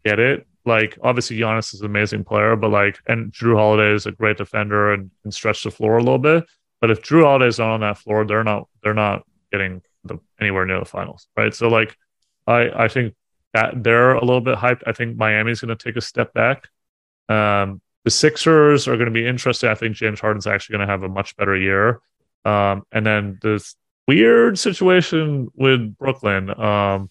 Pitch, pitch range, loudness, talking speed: 110 Hz, 105-120 Hz, -18 LUFS, 205 wpm